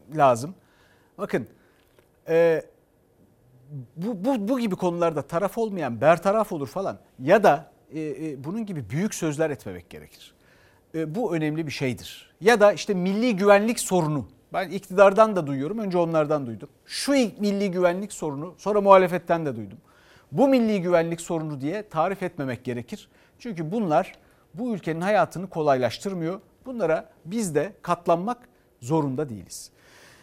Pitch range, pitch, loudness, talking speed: 150-205 Hz, 170 Hz, -24 LUFS, 130 wpm